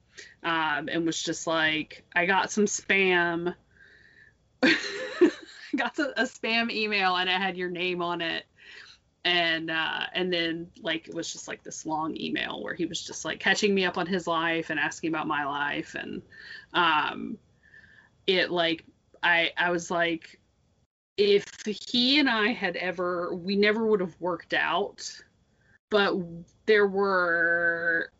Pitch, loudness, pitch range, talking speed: 180 Hz, -26 LUFS, 170-210 Hz, 155 wpm